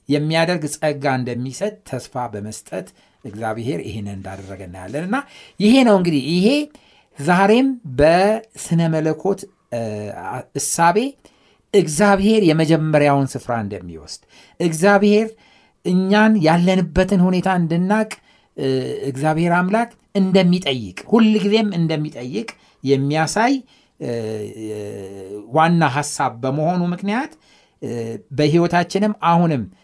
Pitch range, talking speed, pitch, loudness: 130-200 Hz, 80 wpm, 165 Hz, -18 LUFS